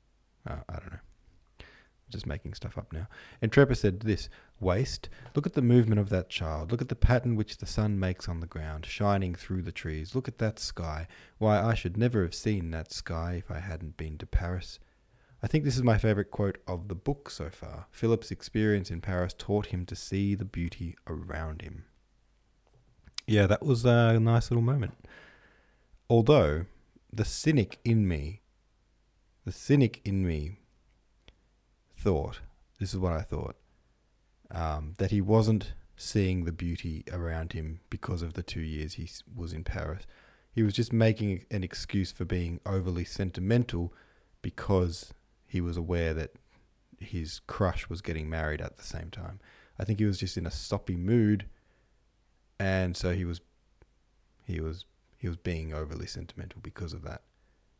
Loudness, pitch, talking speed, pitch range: -31 LUFS, 95 Hz, 170 wpm, 85-110 Hz